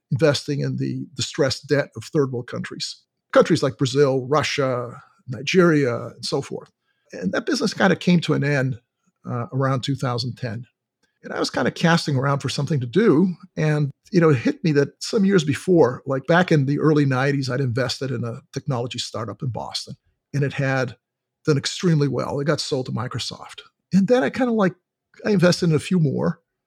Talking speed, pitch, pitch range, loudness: 195 wpm, 140 Hz, 130-165 Hz, -21 LUFS